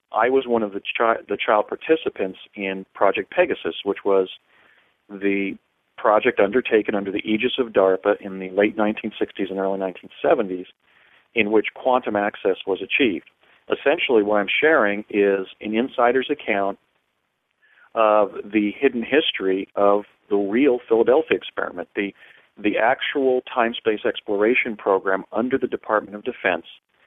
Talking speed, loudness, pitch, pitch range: 140 wpm, -21 LUFS, 105 Hz, 100-125 Hz